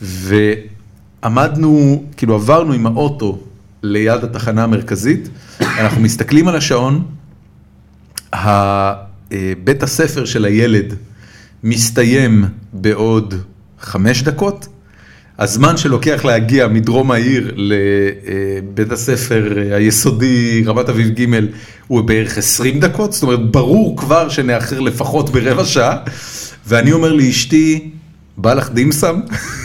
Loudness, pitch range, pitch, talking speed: -13 LUFS, 105-140 Hz, 115 Hz, 100 wpm